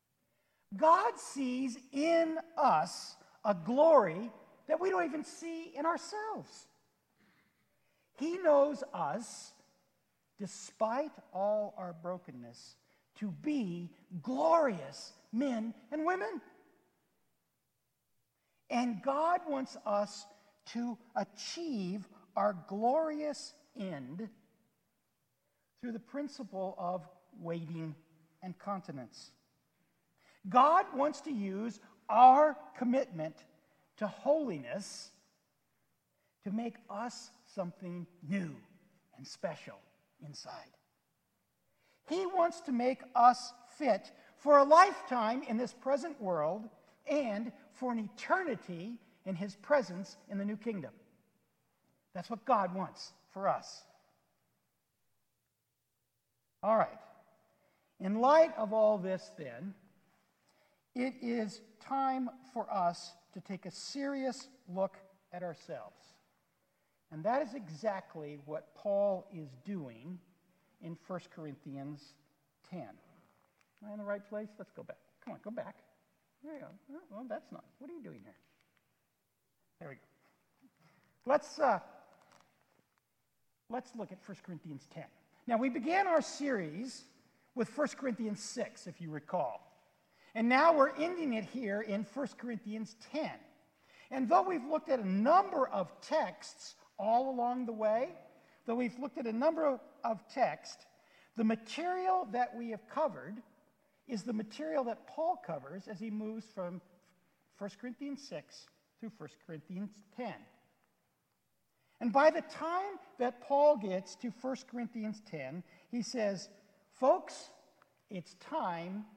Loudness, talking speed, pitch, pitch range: -34 LUFS, 120 wpm, 225 Hz, 190-275 Hz